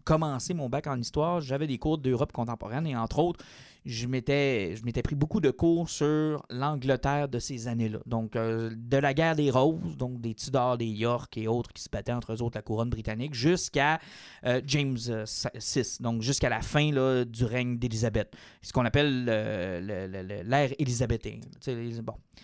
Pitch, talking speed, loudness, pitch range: 125 Hz, 195 wpm, -29 LUFS, 115-145 Hz